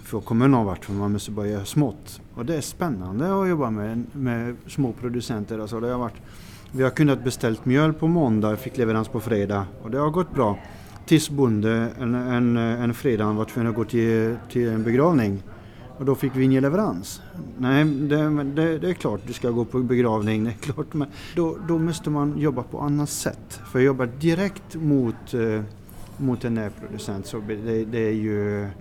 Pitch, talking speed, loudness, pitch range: 120 Hz, 195 wpm, -24 LUFS, 110-140 Hz